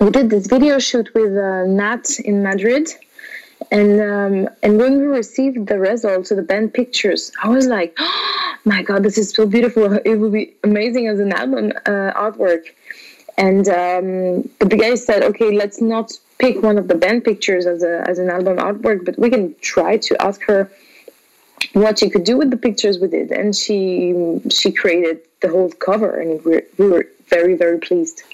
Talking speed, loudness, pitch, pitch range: 195 wpm, -16 LUFS, 210 Hz, 190-235 Hz